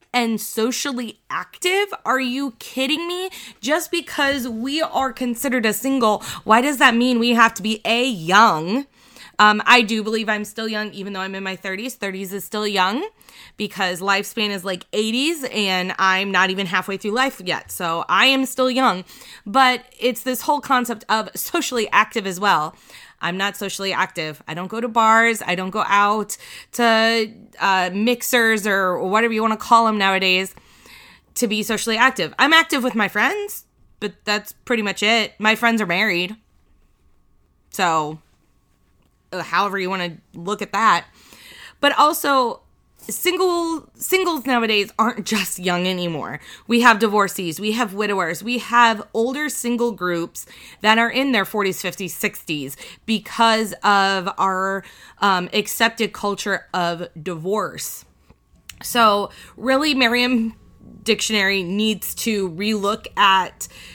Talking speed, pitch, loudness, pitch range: 150 wpm, 215 Hz, -19 LUFS, 195-245 Hz